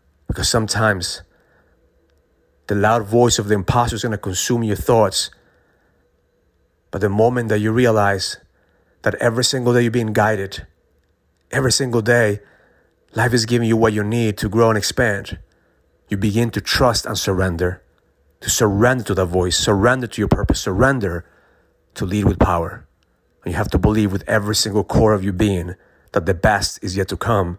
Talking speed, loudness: 175 wpm, -18 LUFS